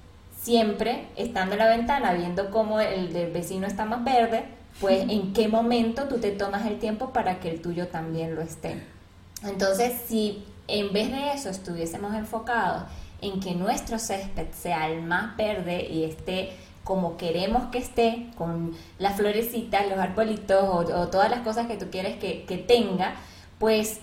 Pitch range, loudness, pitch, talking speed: 180-225 Hz, -27 LUFS, 200 Hz, 170 wpm